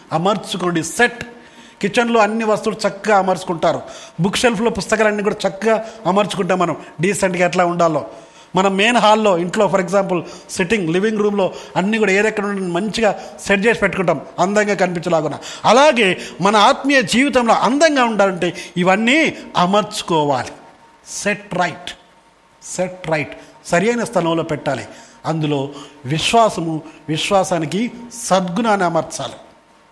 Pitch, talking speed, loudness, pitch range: 195 Hz, 110 wpm, -17 LUFS, 175-215 Hz